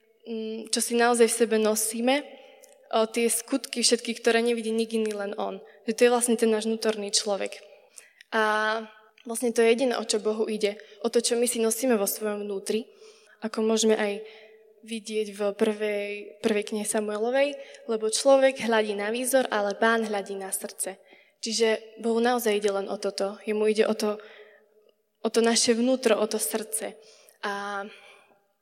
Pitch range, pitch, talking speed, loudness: 210-230 Hz, 220 Hz, 170 wpm, -26 LUFS